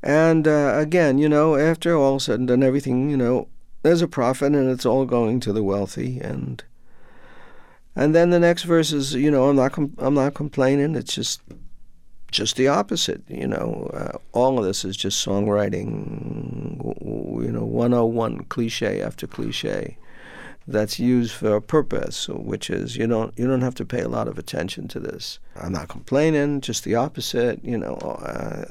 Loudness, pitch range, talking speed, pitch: -22 LUFS, 110-145 Hz, 185 wpm, 130 Hz